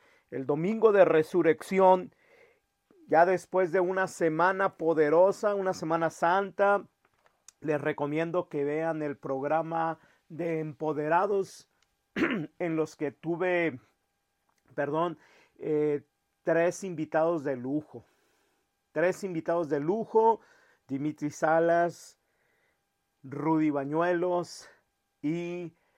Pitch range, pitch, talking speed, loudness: 155-185 Hz, 165 Hz, 90 wpm, -28 LUFS